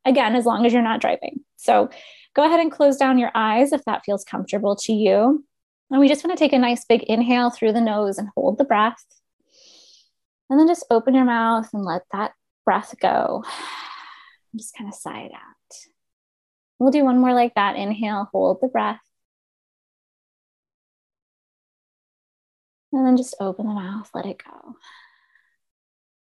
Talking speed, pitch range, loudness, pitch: 170 wpm, 215-270 Hz, -20 LUFS, 235 Hz